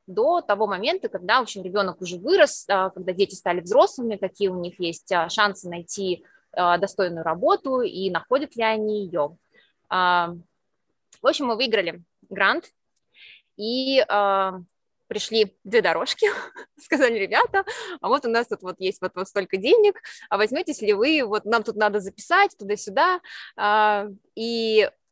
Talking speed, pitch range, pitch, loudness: 135 wpm, 185-285 Hz, 210 Hz, -23 LUFS